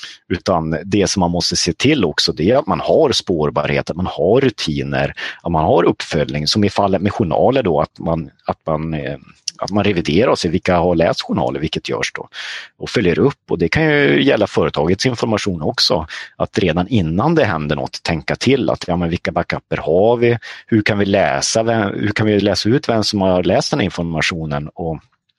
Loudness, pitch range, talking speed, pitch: -17 LUFS, 80-105 Hz, 210 wpm, 90 Hz